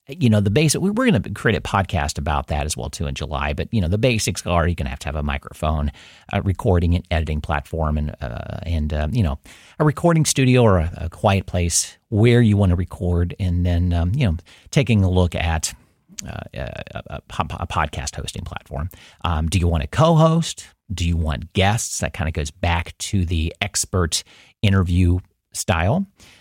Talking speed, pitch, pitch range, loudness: 205 wpm, 90 Hz, 80-105 Hz, -21 LUFS